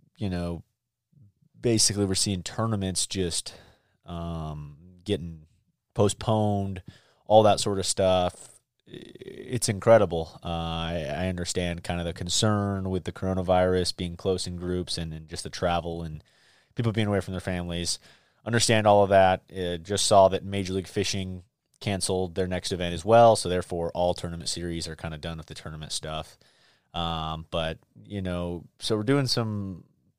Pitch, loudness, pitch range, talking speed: 95 Hz, -26 LUFS, 85-105 Hz, 165 wpm